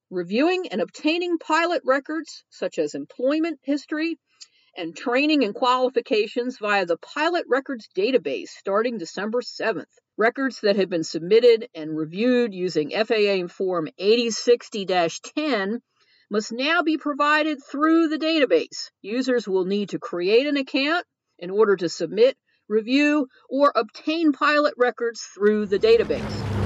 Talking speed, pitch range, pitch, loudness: 135 wpm, 205-305 Hz, 250 Hz, -22 LUFS